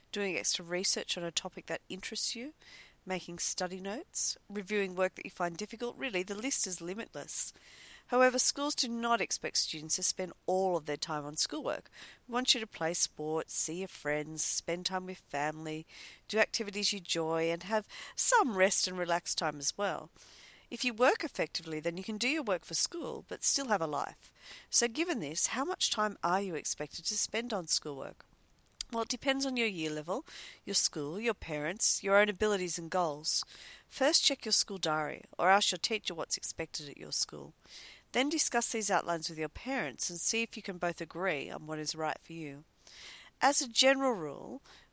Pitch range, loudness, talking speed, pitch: 165-230 Hz, -32 LUFS, 195 wpm, 190 Hz